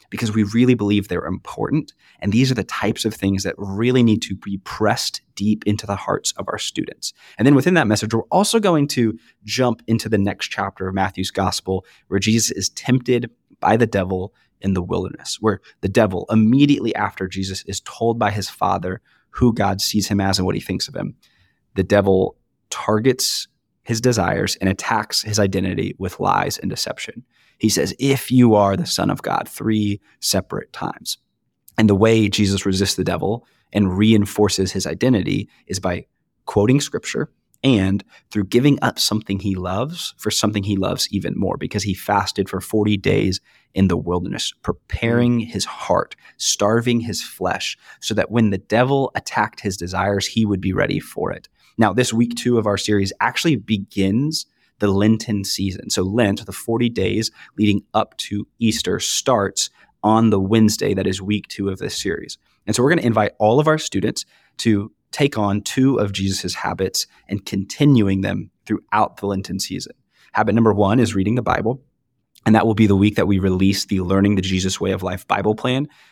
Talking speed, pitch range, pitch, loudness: 190 wpm, 95-115 Hz, 105 Hz, -19 LUFS